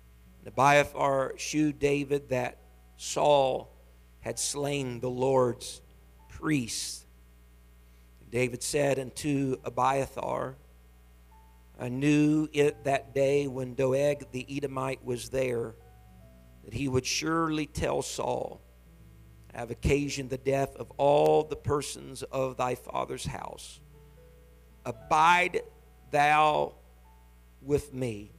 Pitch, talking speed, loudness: 125 Hz, 105 wpm, -29 LUFS